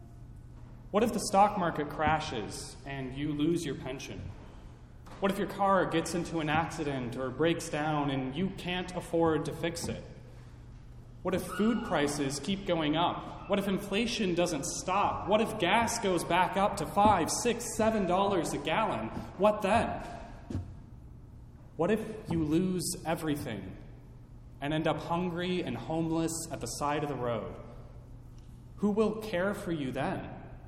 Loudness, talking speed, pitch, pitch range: -31 LUFS, 155 wpm, 165 Hz, 135-190 Hz